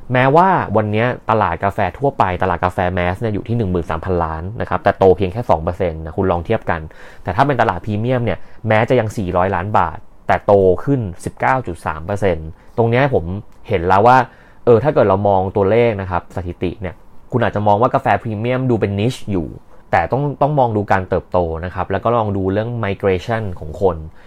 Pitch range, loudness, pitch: 90-115 Hz, -17 LUFS, 100 Hz